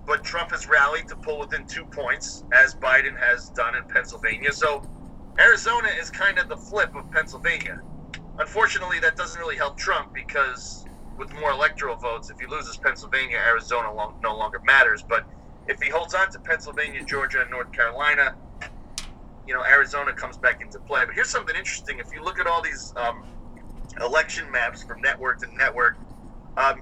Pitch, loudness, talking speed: 180 Hz, -22 LUFS, 175 wpm